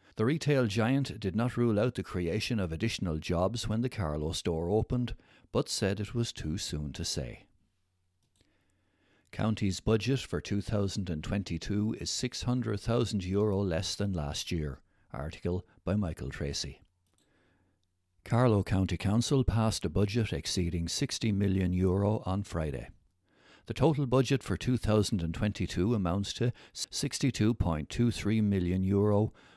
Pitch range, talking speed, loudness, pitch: 90-110 Hz, 120 wpm, -31 LUFS, 100 Hz